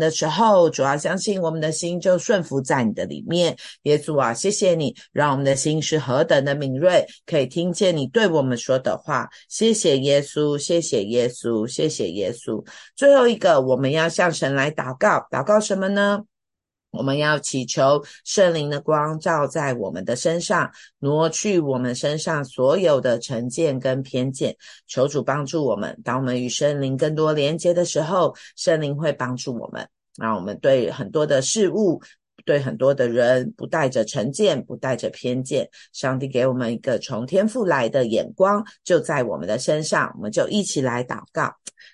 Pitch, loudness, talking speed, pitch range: 150 Hz, -21 LUFS, 265 characters per minute, 130-175 Hz